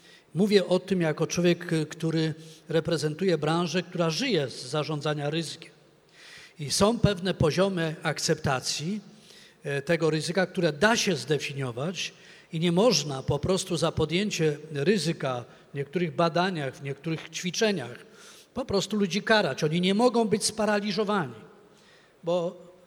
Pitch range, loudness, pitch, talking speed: 155-190 Hz, -27 LUFS, 170 Hz, 125 wpm